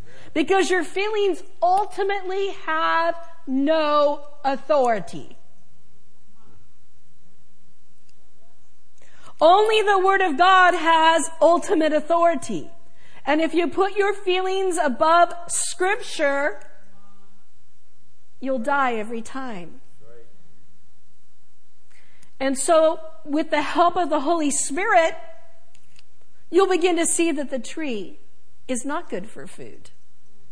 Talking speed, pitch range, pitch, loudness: 95 wpm, 270-360 Hz, 325 Hz, -21 LUFS